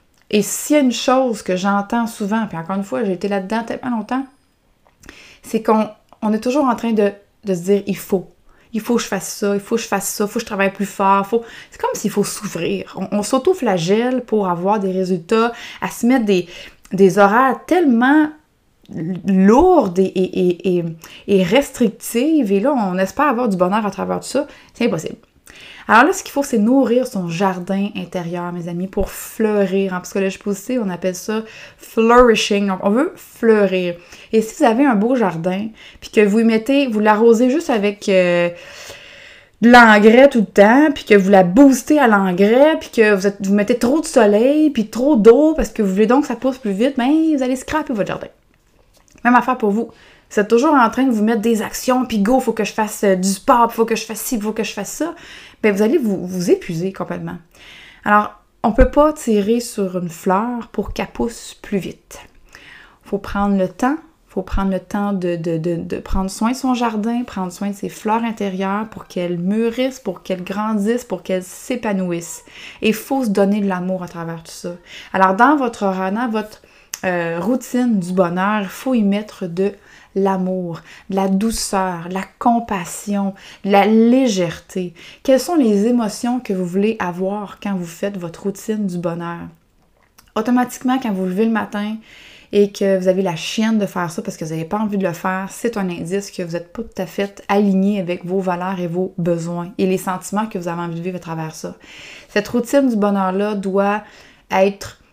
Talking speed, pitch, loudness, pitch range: 210 wpm, 205 Hz, -17 LUFS, 190-235 Hz